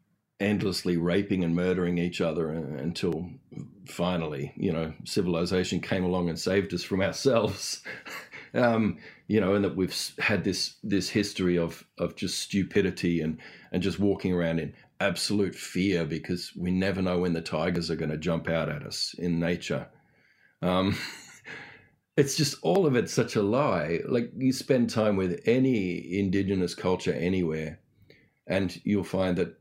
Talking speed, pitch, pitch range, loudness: 160 wpm, 90 Hz, 85-100 Hz, -28 LUFS